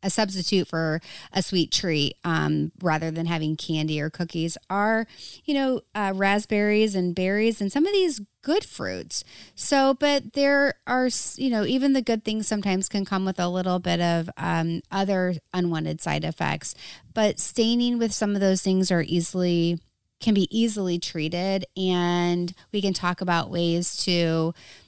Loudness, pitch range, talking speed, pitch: -24 LUFS, 170-215 Hz, 165 wpm, 190 Hz